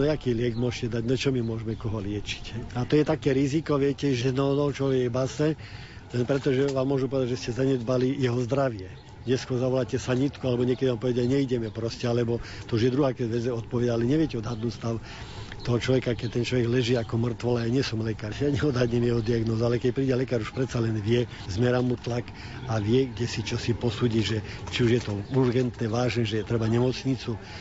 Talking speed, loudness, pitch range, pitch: 215 wpm, -27 LUFS, 115-130 Hz, 120 Hz